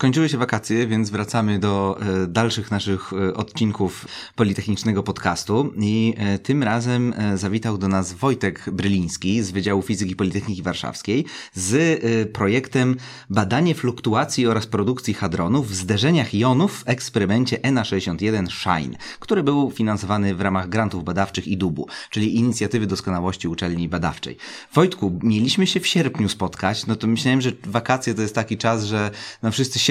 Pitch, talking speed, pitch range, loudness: 110 Hz, 155 wpm, 100-120 Hz, -21 LUFS